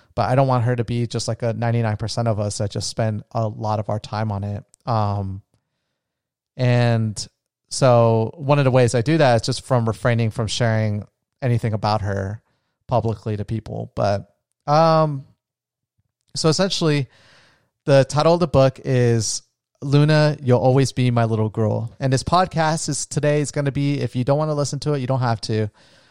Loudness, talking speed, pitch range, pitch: -20 LUFS, 190 wpm, 110-135 Hz, 120 Hz